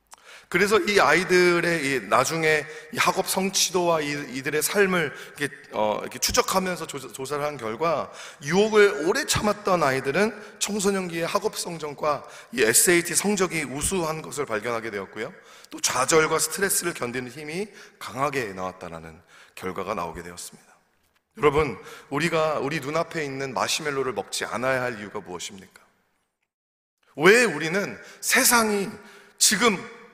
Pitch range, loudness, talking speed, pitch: 135-195 Hz, -23 LUFS, 300 characters per minute, 160 Hz